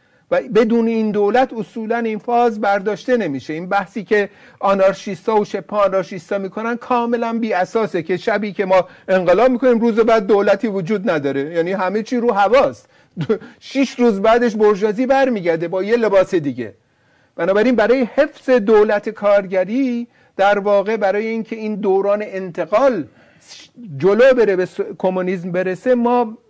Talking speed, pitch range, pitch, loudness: 145 wpm, 190-235 Hz, 210 Hz, -17 LUFS